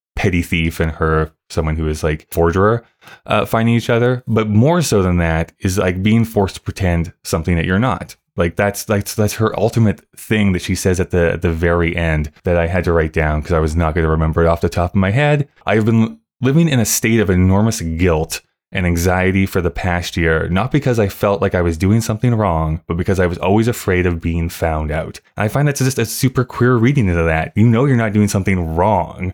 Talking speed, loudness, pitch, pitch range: 240 wpm, -16 LUFS, 95 Hz, 85-110 Hz